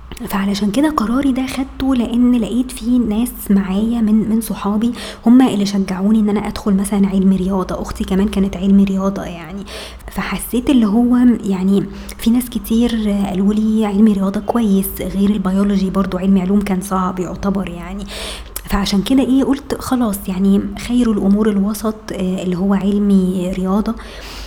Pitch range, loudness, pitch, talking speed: 195-225 Hz, -16 LUFS, 205 Hz, 150 wpm